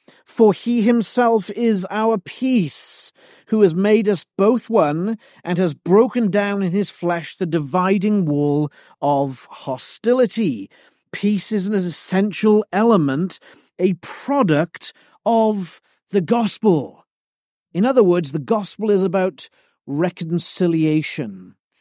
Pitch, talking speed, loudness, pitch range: 200 Hz, 115 wpm, -19 LUFS, 175-220 Hz